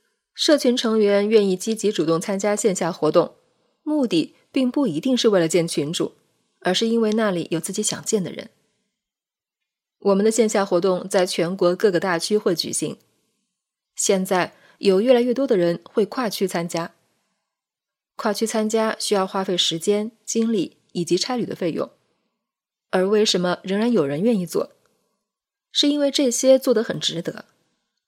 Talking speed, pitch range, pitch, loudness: 240 characters per minute, 185-235 Hz, 210 Hz, -21 LUFS